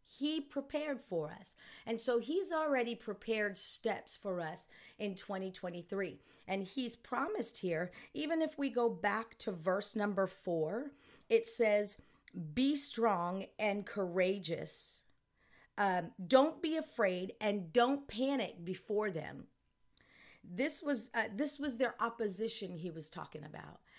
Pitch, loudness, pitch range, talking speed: 220 Hz, -37 LUFS, 190-265 Hz, 135 wpm